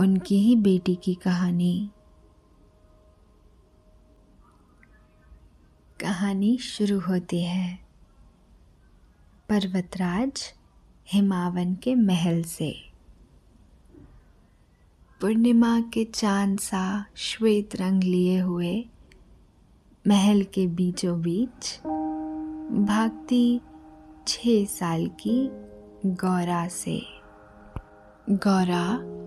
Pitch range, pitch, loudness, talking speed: 155-205 Hz, 185 Hz, -25 LUFS, 65 wpm